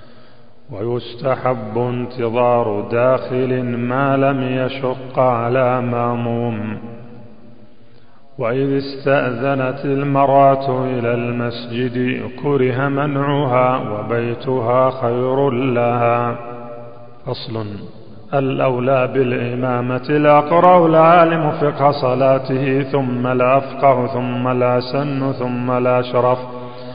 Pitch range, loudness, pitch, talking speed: 120-135 Hz, -17 LUFS, 125 Hz, 70 wpm